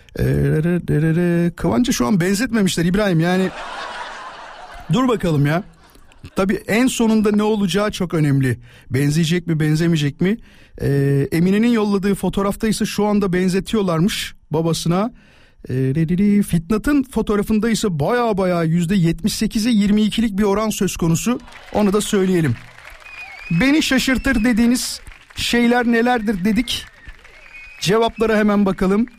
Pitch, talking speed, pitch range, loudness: 200 Hz, 105 wpm, 170-220 Hz, -18 LUFS